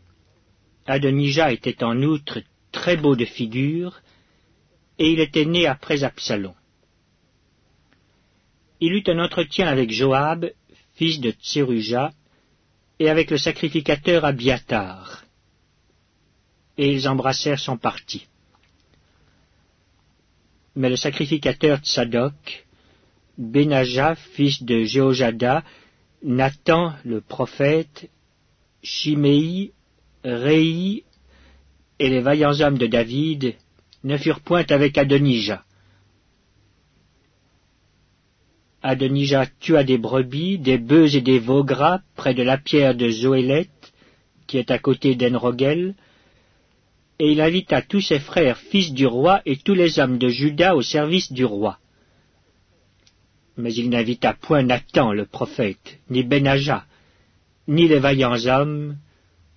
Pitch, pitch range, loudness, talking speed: 135 Hz, 115-150 Hz, -20 LUFS, 110 wpm